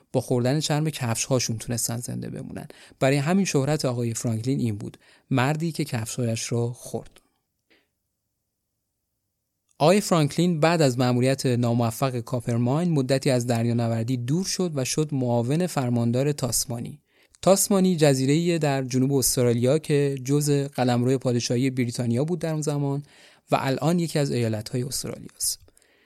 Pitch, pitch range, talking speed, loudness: 130 Hz, 120-145 Hz, 130 wpm, -24 LUFS